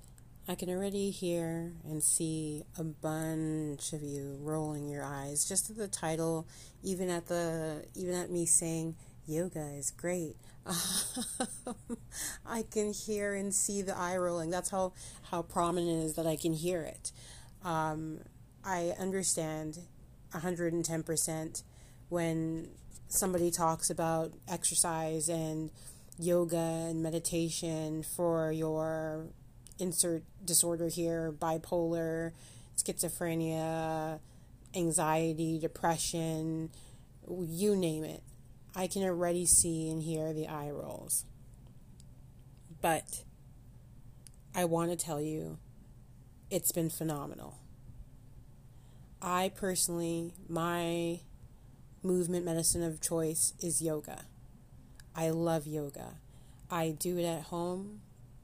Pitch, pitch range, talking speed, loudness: 160 Hz, 150-175 Hz, 110 wpm, -34 LUFS